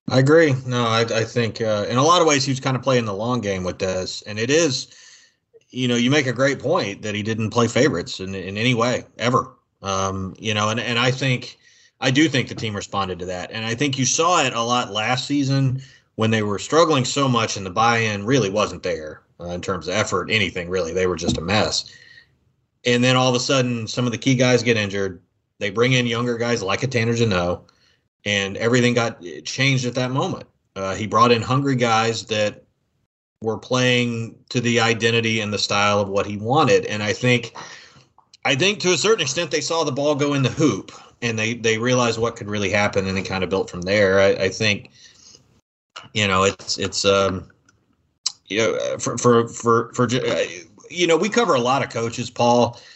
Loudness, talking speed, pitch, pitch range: -20 LUFS, 220 wpm, 120 Hz, 105-130 Hz